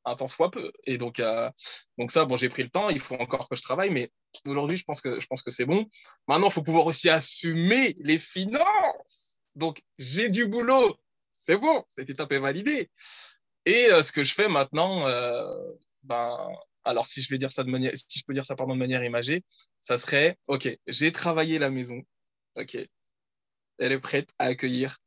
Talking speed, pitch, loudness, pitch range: 205 wpm, 140 Hz, -26 LUFS, 130-180 Hz